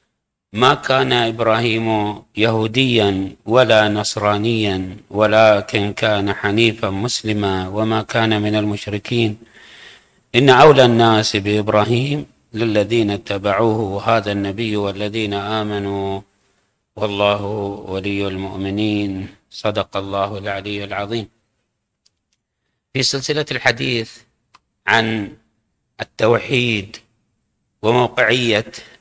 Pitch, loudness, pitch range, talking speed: 105 Hz, -17 LUFS, 100-115 Hz, 75 wpm